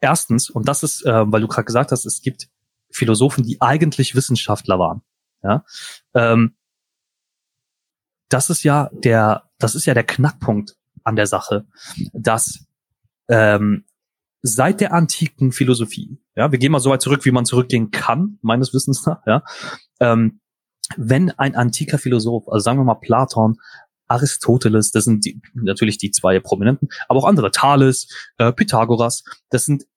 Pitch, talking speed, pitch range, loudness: 125 Hz, 155 wpm, 115-140 Hz, -17 LUFS